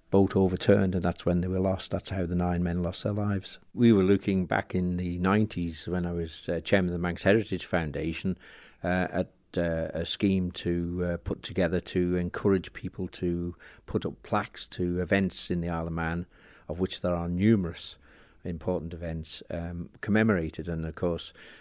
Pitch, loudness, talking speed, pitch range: 90 Hz, -29 LUFS, 190 wpm, 85-95 Hz